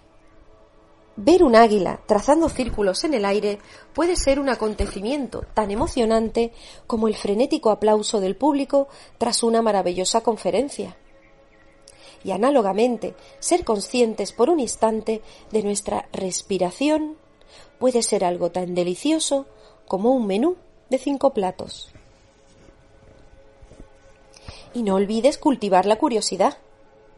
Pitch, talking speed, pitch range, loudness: 215 Hz, 115 wpm, 180-255 Hz, -21 LUFS